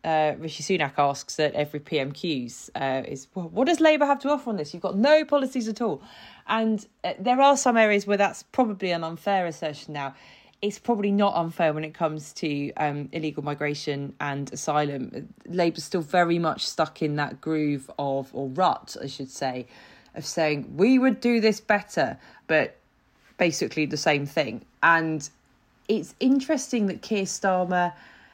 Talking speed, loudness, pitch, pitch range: 175 wpm, -25 LUFS, 165 Hz, 145-205 Hz